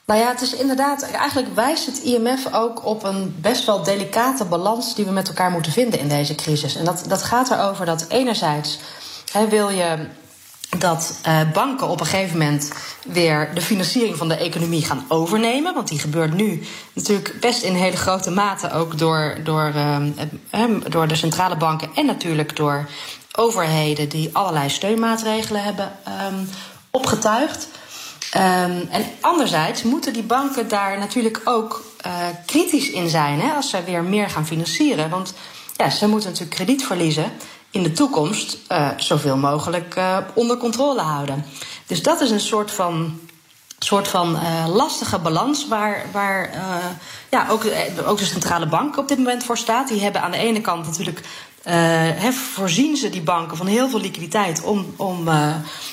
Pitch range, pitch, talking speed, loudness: 165-225 Hz, 190 Hz, 165 wpm, -20 LUFS